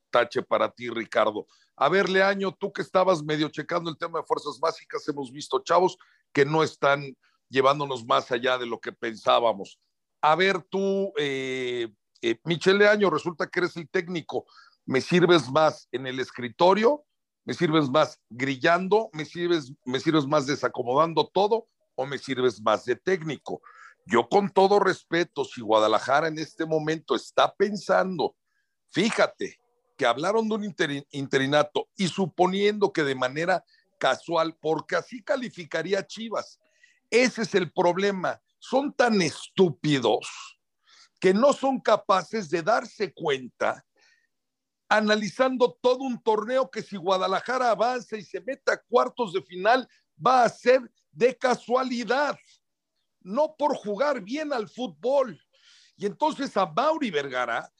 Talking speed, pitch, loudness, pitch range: 145 wpm, 185 Hz, -25 LUFS, 150-230 Hz